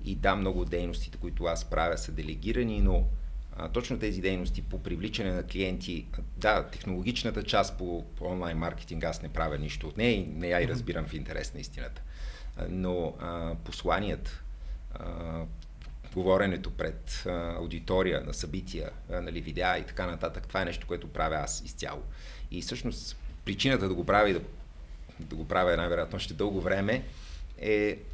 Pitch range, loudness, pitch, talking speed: 80-95 Hz, -32 LUFS, 85 Hz, 165 wpm